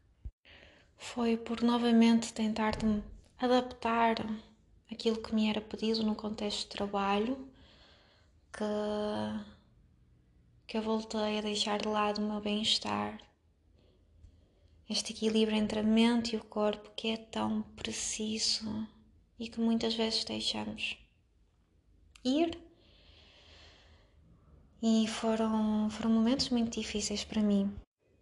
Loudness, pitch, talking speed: -32 LUFS, 215 Hz, 110 wpm